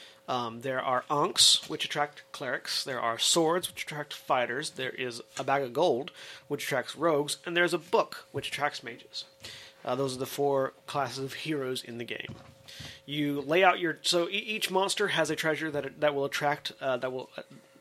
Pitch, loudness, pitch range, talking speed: 145 Hz, -29 LUFS, 135-165 Hz, 200 wpm